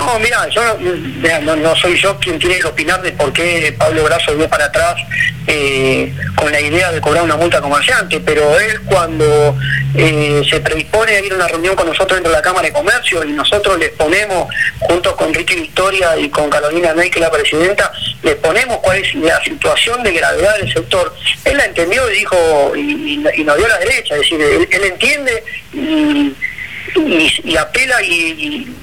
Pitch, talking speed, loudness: 175 Hz, 200 wpm, -12 LUFS